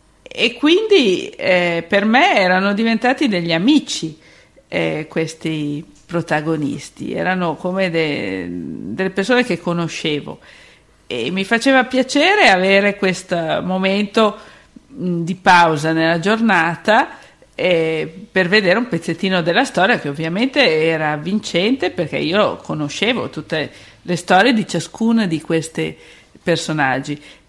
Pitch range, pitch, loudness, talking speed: 160-225 Hz, 180 Hz, -16 LUFS, 115 wpm